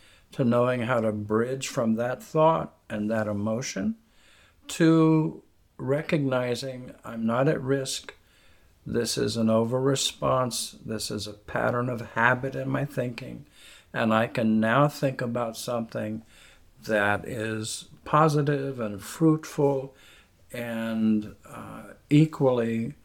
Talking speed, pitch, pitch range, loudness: 120 wpm, 120 Hz, 110-135 Hz, -26 LUFS